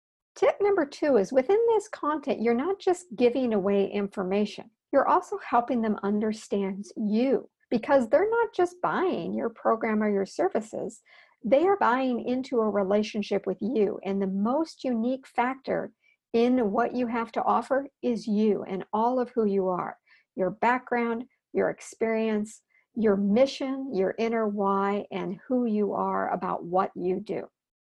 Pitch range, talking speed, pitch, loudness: 205-265 Hz, 155 wpm, 230 Hz, -27 LUFS